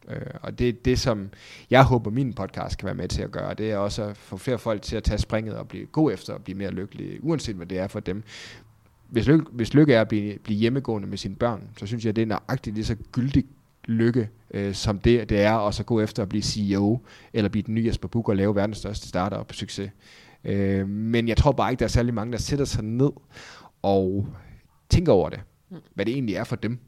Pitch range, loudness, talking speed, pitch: 100-120 Hz, -25 LUFS, 250 wpm, 110 Hz